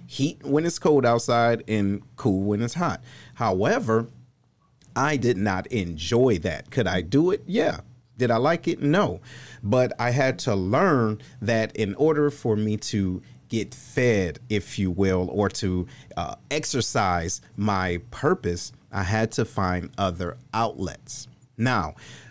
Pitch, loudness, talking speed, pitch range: 115 Hz, -25 LUFS, 150 wpm, 100-130 Hz